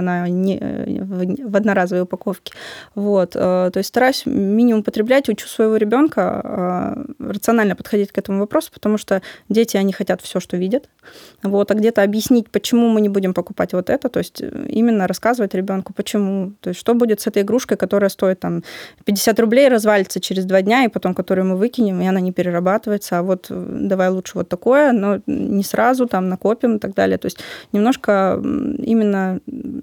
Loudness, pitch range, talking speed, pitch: -18 LUFS, 190-230 Hz, 175 wpm, 205 Hz